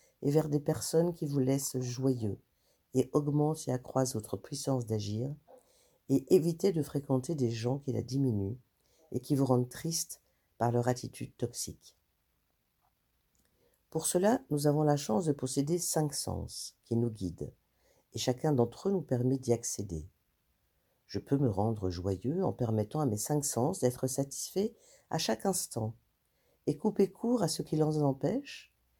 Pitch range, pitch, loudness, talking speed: 115-155 Hz, 130 Hz, -32 LUFS, 160 wpm